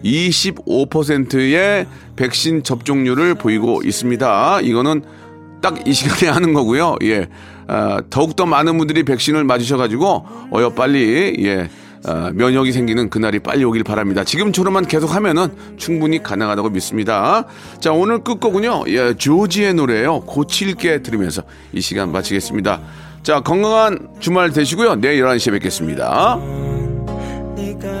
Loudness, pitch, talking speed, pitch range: -16 LUFS, 140 Hz, 300 characters per minute, 110-175 Hz